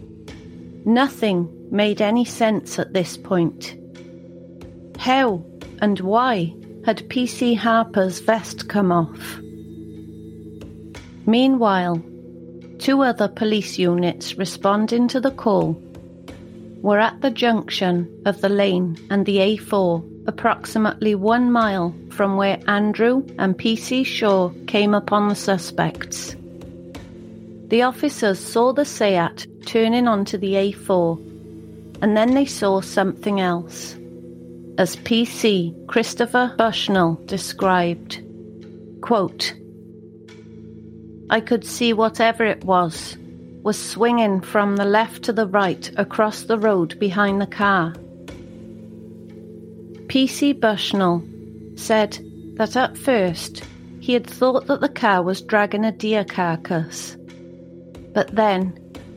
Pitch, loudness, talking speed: 195 Hz, -20 LUFS, 110 wpm